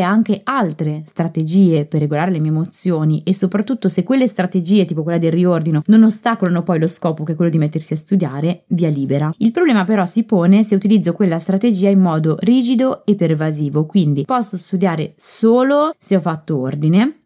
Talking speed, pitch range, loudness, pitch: 185 wpm, 160-210 Hz, -16 LUFS, 180 Hz